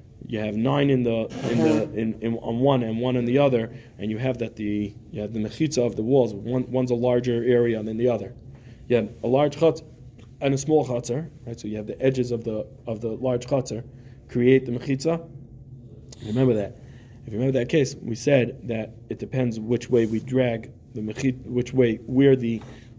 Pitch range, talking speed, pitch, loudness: 115-130 Hz, 215 wpm, 120 Hz, -24 LUFS